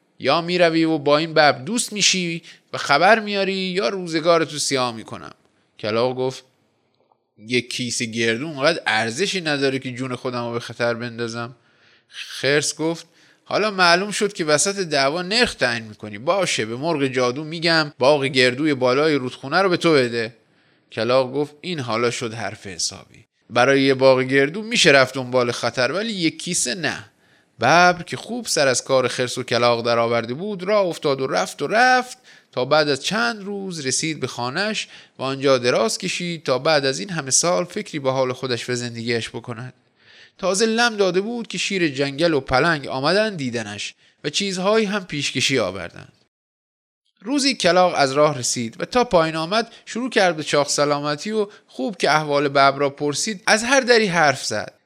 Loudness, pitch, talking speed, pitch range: -20 LUFS, 145 Hz, 175 wpm, 125-185 Hz